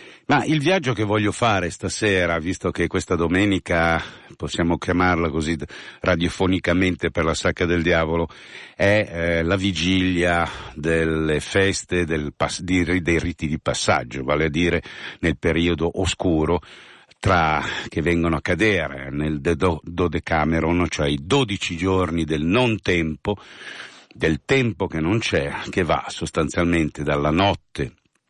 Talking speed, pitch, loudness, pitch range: 140 wpm, 85 Hz, -21 LUFS, 80-95 Hz